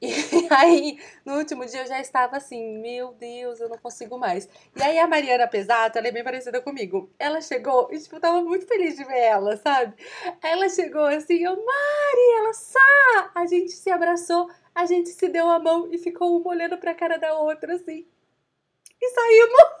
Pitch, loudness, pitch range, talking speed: 320 Hz, -21 LUFS, 255-345 Hz, 200 wpm